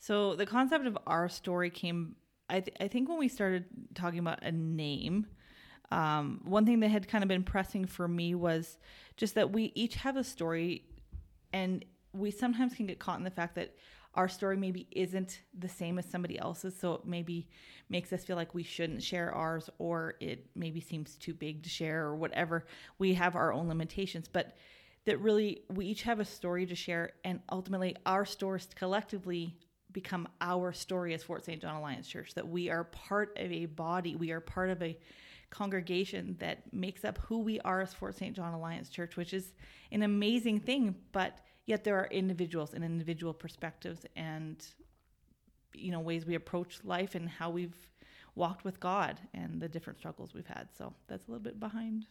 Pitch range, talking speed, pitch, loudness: 170-200 Hz, 195 wpm, 180 Hz, -36 LUFS